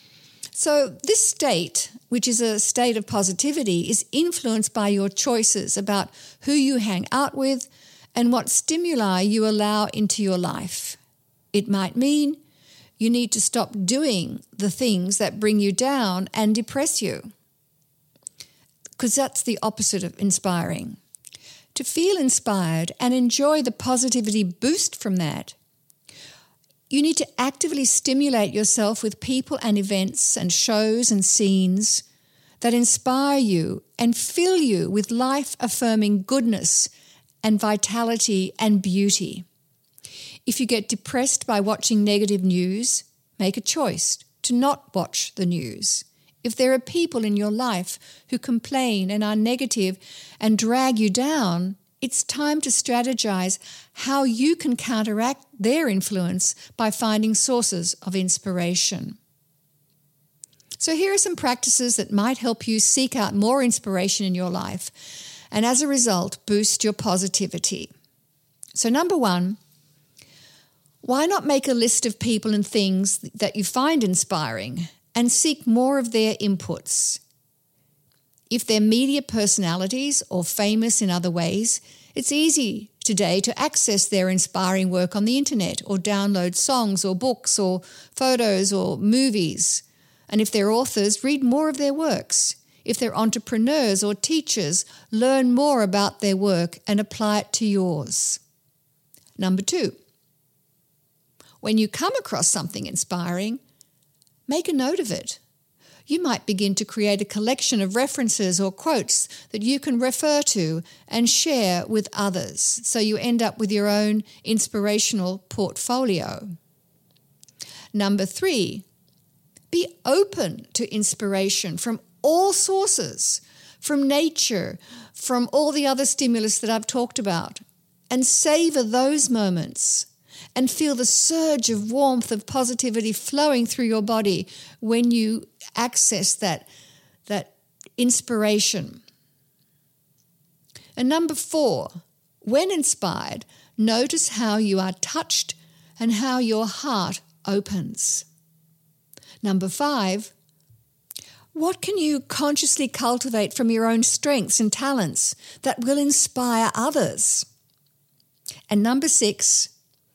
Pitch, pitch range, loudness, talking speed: 215 Hz, 185-250 Hz, -21 LUFS, 130 wpm